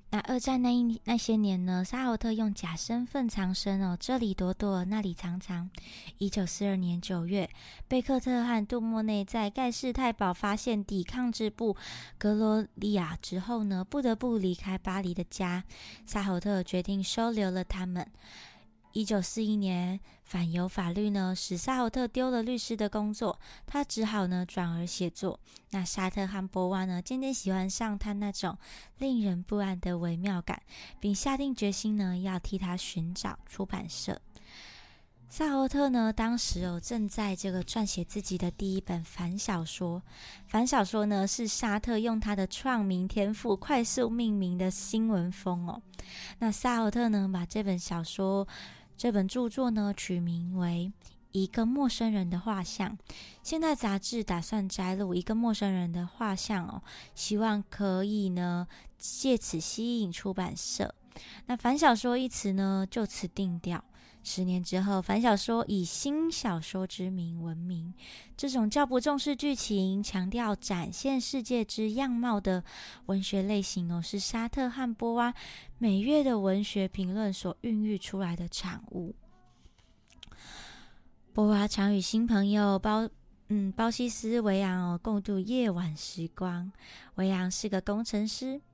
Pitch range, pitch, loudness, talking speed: 185-230 Hz, 200 Hz, -31 LUFS, 230 characters per minute